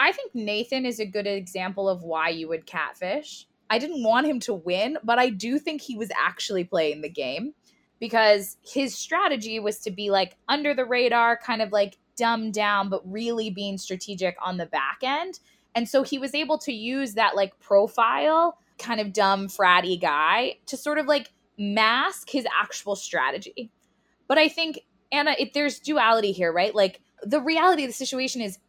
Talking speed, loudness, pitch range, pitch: 190 wpm, -24 LUFS, 200-275 Hz, 225 Hz